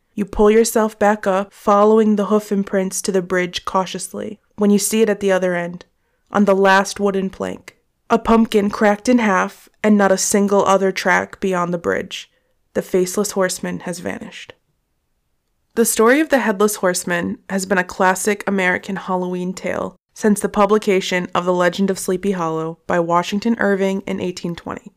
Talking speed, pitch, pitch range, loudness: 175 wpm, 195 Hz, 185-210 Hz, -18 LUFS